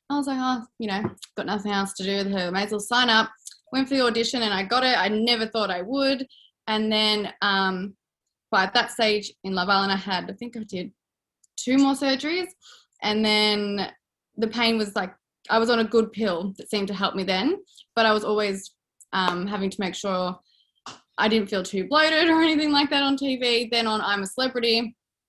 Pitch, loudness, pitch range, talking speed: 215 Hz, -23 LUFS, 195-245 Hz, 220 wpm